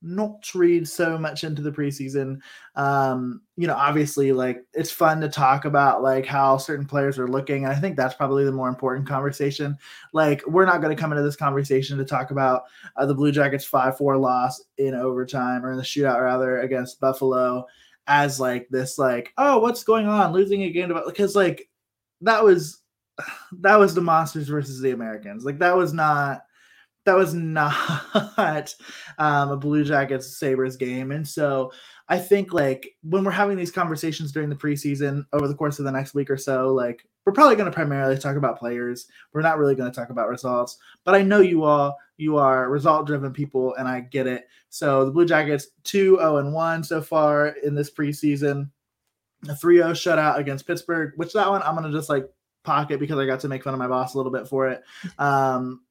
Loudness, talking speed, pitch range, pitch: -22 LUFS, 205 wpm, 130-160 Hz, 145 Hz